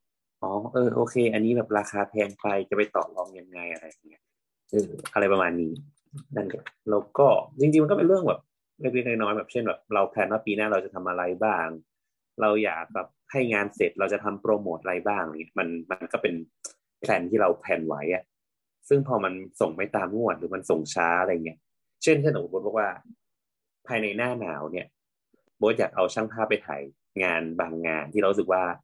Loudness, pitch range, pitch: -26 LUFS, 90-115 Hz, 105 Hz